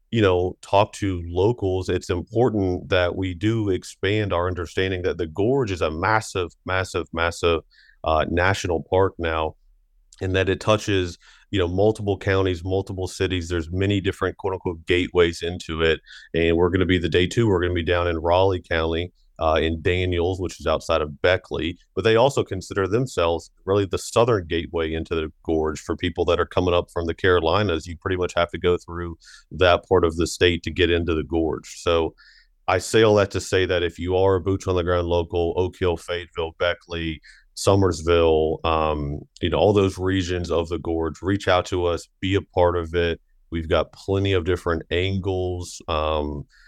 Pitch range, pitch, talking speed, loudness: 85-95 Hz, 90 Hz, 195 wpm, -22 LUFS